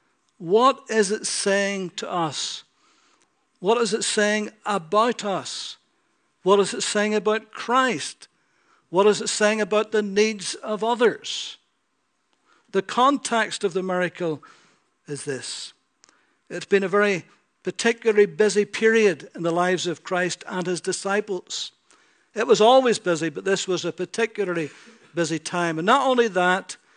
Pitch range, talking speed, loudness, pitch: 180-225 Hz, 140 wpm, -22 LUFS, 205 Hz